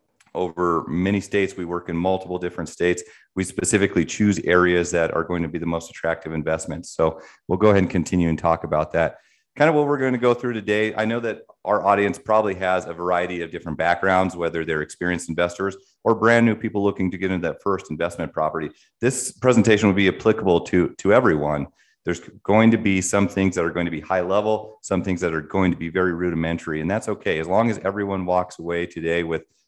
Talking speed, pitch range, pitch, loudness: 220 wpm, 85-100 Hz, 90 Hz, -22 LUFS